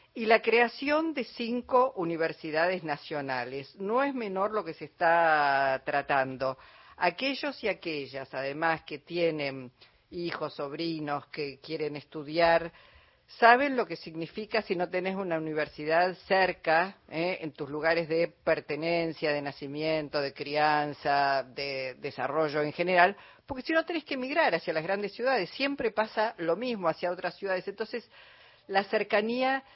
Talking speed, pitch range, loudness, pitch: 140 wpm, 150-215 Hz, -29 LUFS, 165 Hz